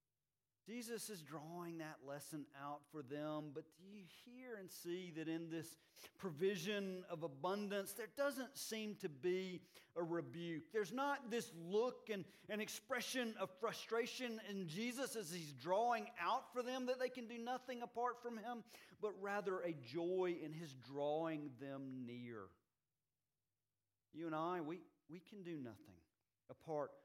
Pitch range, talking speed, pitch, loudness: 150-225 Hz, 155 wpm, 180 Hz, -46 LUFS